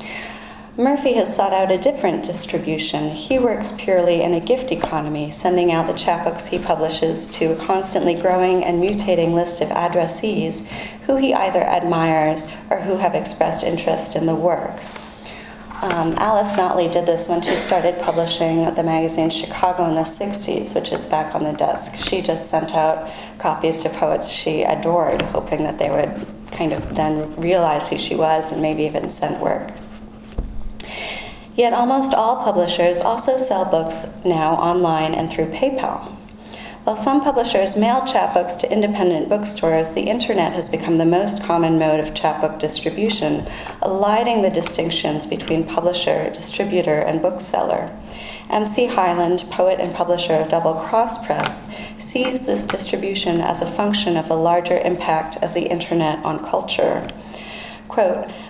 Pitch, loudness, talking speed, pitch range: 175 Hz, -19 LUFS, 155 wpm, 160-205 Hz